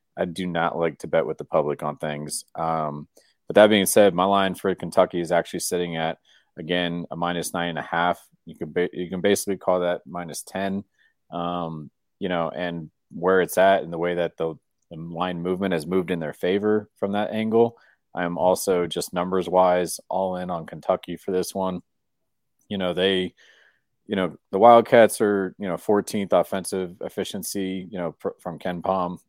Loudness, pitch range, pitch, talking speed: -23 LUFS, 85-95 Hz, 90 Hz, 195 wpm